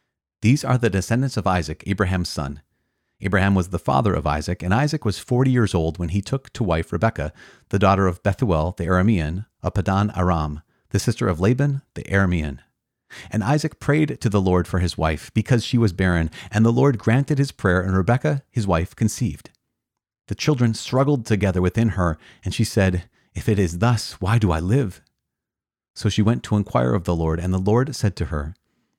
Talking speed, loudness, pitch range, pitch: 200 wpm, -21 LUFS, 90-120 Hz, 100 Hz